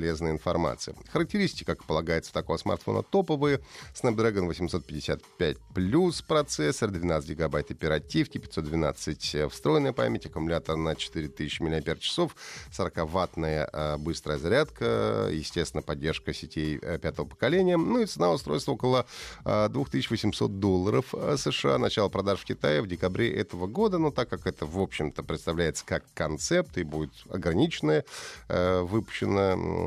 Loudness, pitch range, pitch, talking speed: -29 LUFS, 80-115 Hz, 85 Hz, 120 wpm